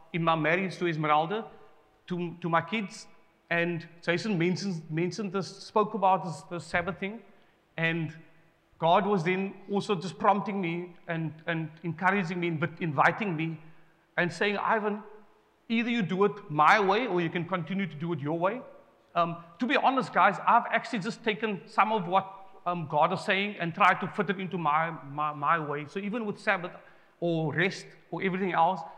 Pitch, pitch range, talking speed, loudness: 180 Hz, 165-200 Hz, 180 wpm, -29 LUFS